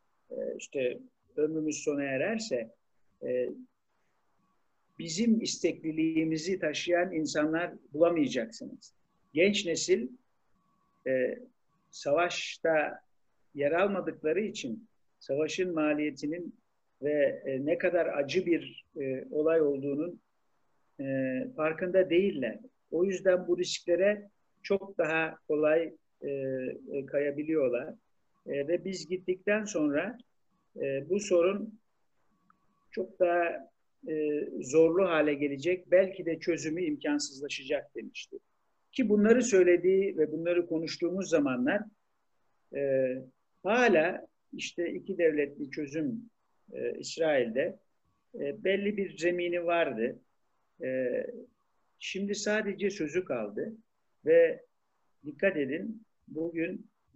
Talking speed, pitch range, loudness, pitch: 85 wpm, 155-205 Hz, -30 LUFS, 175 Hz